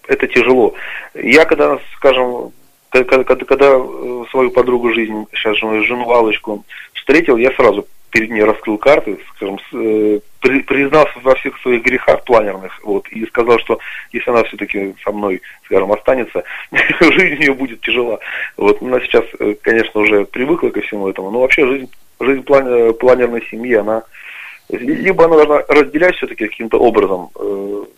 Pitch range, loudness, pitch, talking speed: 105-135 Hz, -13 LUFS, 120 Hz, 145 wpm